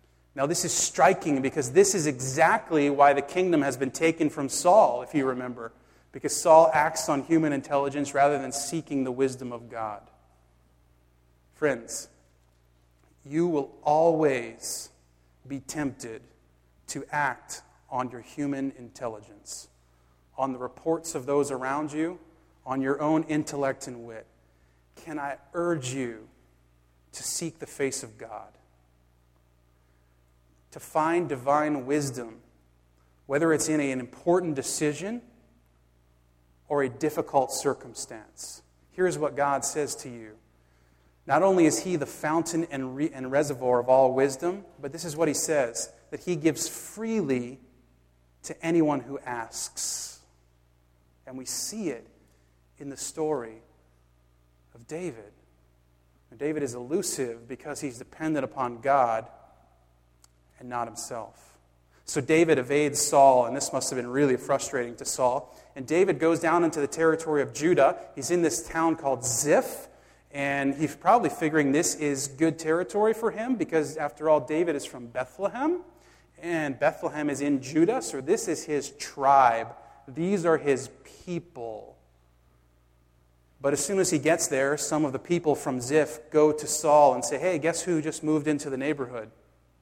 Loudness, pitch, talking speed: -26 LUFS, 135 Hz, 145 wpm